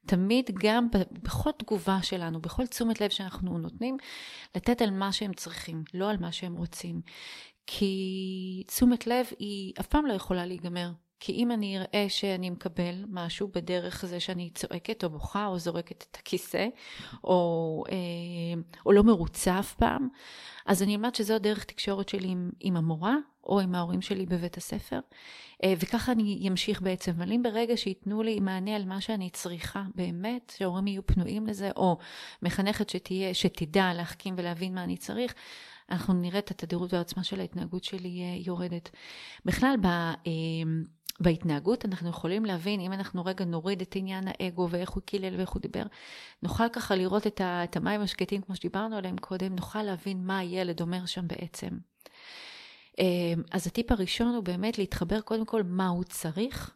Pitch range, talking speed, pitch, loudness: 180-210 Hz, 160 wpm, 190 Hz, -31 LUFS